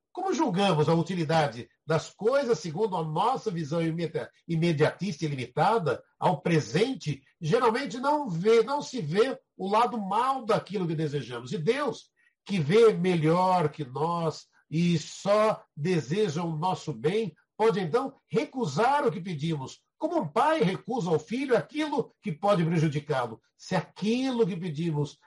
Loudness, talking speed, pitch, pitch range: -27 LUFS, 145 wpm, 180 Hz, 155-225 Hz